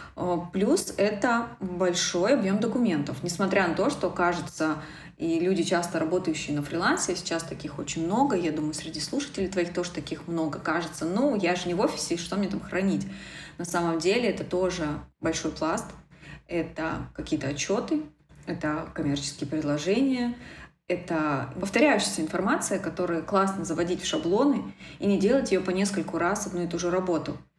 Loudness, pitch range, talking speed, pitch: -27 LUFS, 160-195 Hz, 160 wpm, 175 Hz